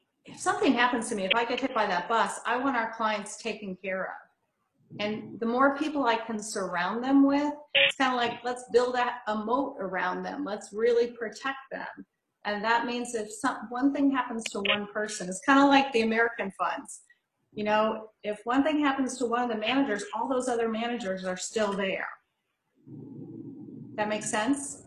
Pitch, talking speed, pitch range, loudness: 230 Hz, 195 wpm, 210-255 Hz, -28 LUFS